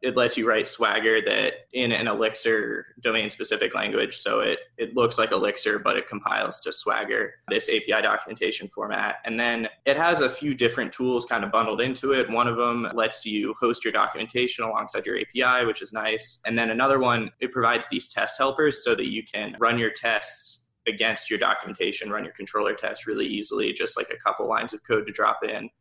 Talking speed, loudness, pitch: 205 wpm, -24 LUFS, 135 Hz